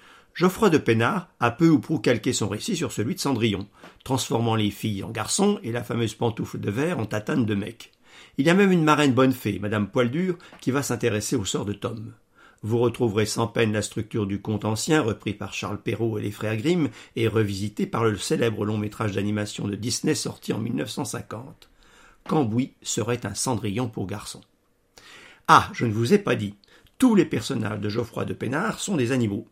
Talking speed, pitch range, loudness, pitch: 200 wpm, 105-130 Hz, -24 LUFS, 115 Hz